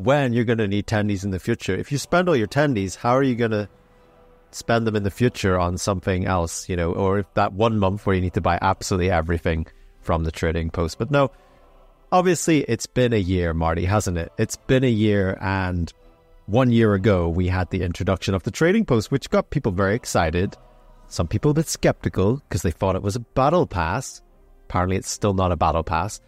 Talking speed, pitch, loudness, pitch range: 220 wpm, 100 Hz, -22 LUFS, 90-120 Hz